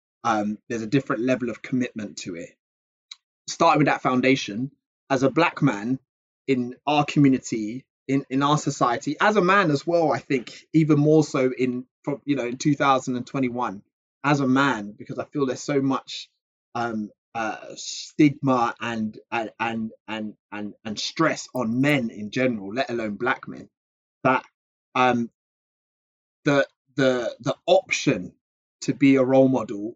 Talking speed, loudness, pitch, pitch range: 155 wpm, -23 LUFS, 130 Hz, 120-140 Hz